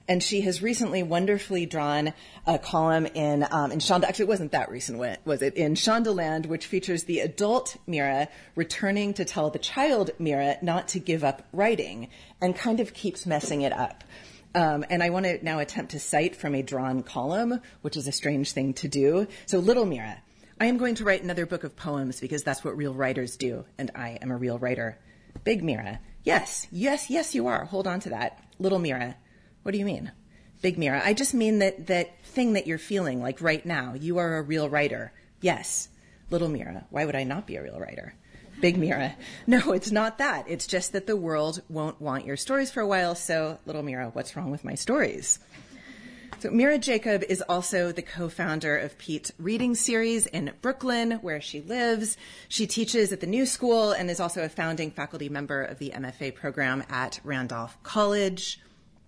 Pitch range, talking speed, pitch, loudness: 145-205 Hz, 200 wpm, 170 Hz, -27 LUFS